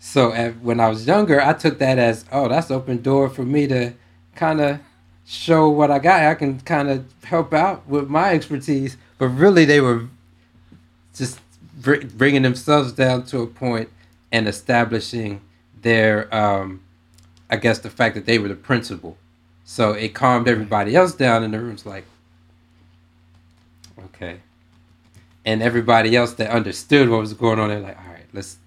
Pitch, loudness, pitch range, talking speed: 115 Hz, -18 LUFS, 90-135 Hz, 165 wpm